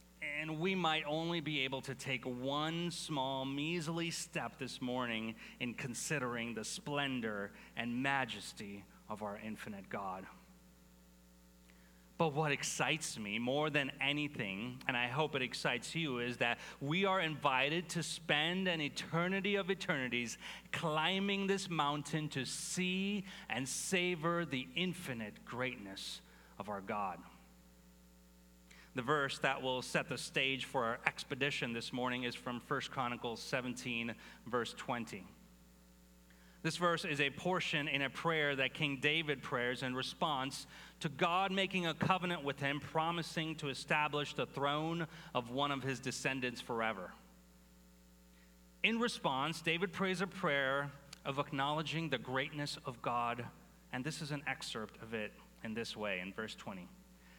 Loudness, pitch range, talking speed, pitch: -38 LUFS, 120-160 Hz, 145 wpm, 140 Hz